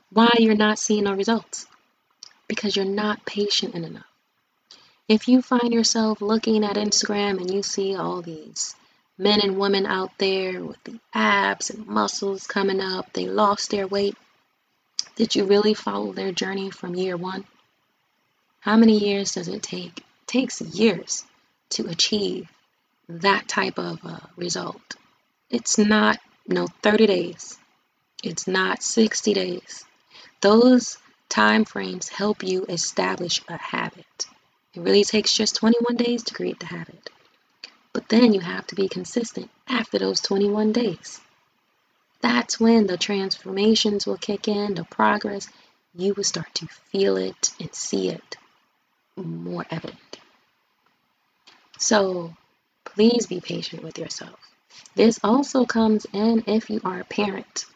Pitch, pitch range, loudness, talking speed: 205 Hz, 185-220 Hz, -22 LUFS, 145 wpm